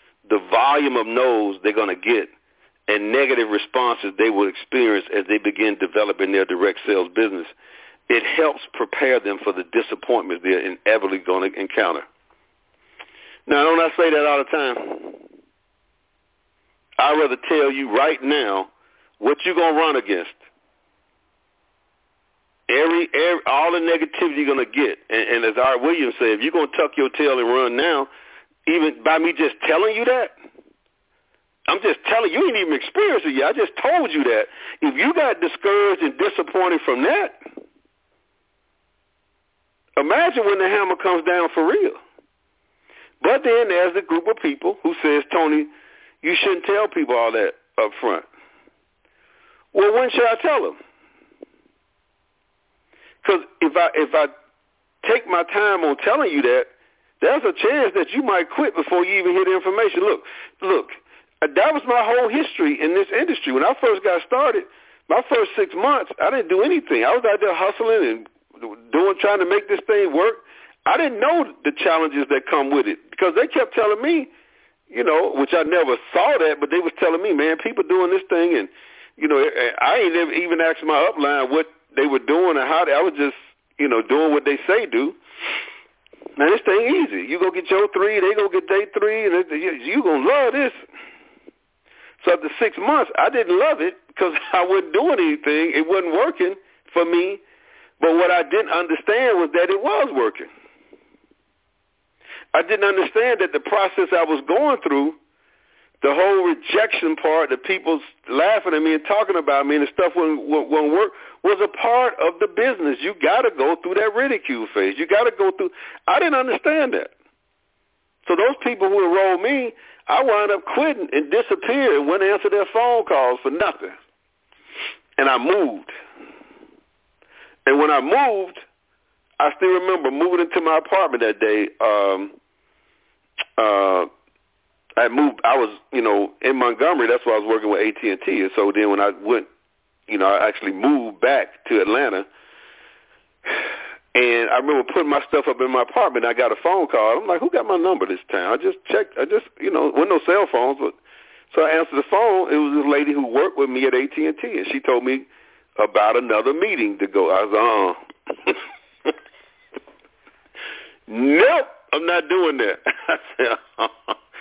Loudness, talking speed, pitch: -19 LUFS, 185 wpm, 310 Hz